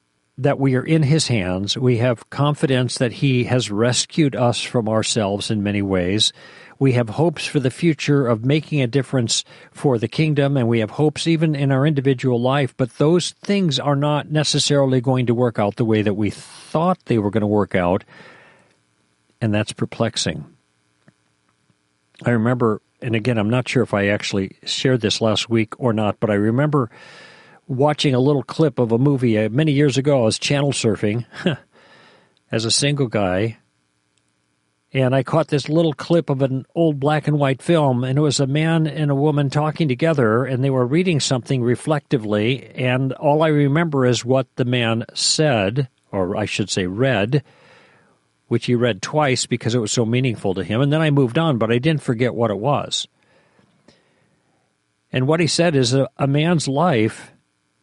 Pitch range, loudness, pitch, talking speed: 110-145 Hz, -19 LUFS, 130 Hz, 185 wpm